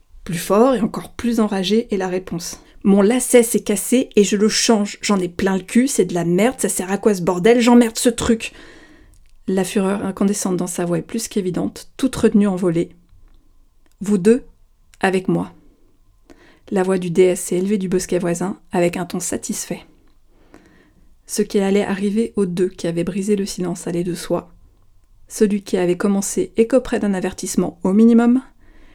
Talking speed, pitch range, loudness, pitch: 180 wpm, 180-220 Hz, -18 LUFS, 195 Hz